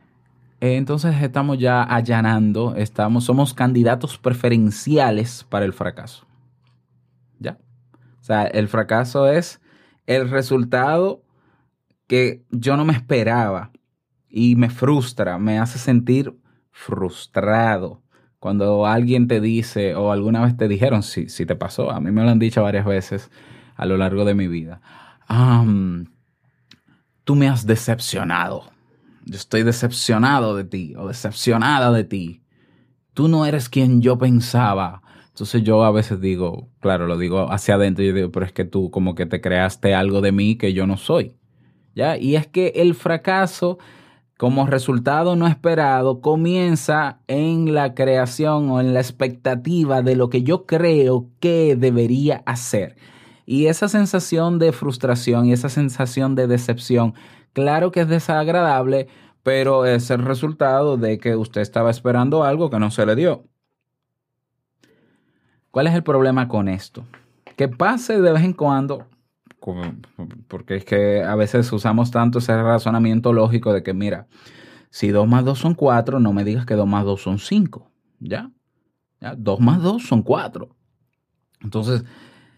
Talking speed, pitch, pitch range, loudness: 150 wpm, 125 Hz, 105-135 Hz, -19 LUFS